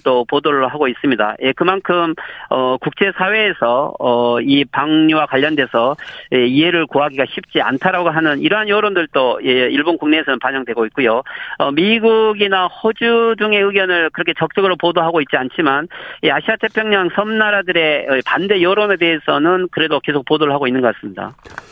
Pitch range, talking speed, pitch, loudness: 140-200 Hz, 375 characters per minute, 165 Hz, -15 LUFS